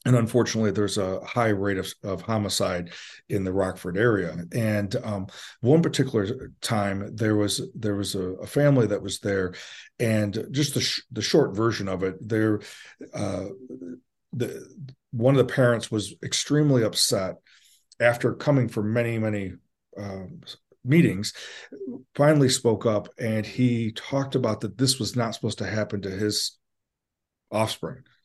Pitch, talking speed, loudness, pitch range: 110 Hz, 150 wpm, -25 LUFS, 100-125 Hz